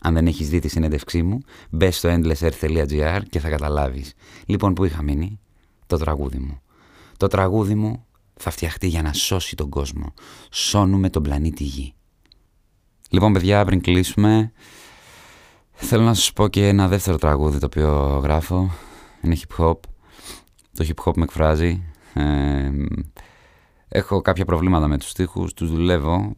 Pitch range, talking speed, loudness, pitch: 75-95 Hz, 150 wpm, -21 LUFS, 85 Hz